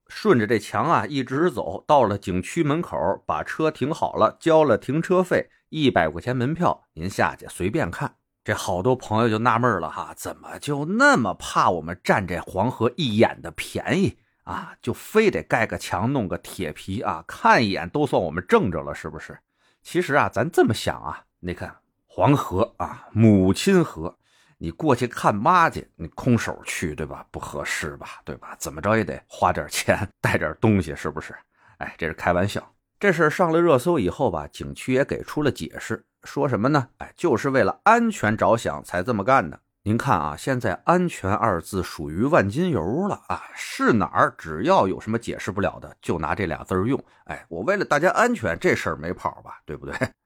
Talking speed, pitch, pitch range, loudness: 280 characters per minute, 115 Hz, 90-155 Hz, -23 LUFS